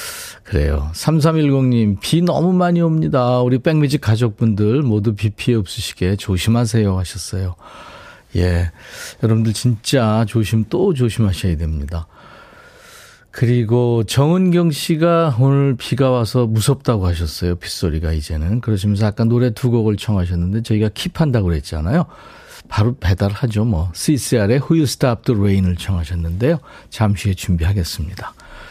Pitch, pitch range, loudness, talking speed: 110 Hz, 95-130 Hz, -17 LUFS, 335 characters per minute